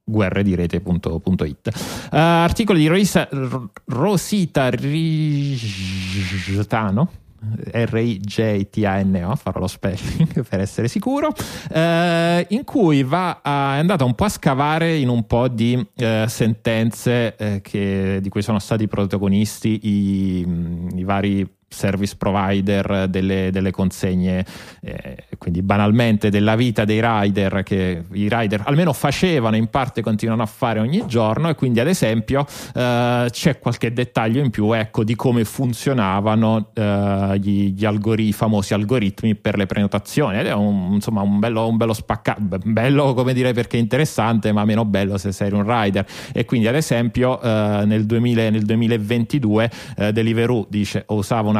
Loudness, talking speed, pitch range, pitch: -19 LUFS, 135 wpm, 100-125 Hz, 110 Hz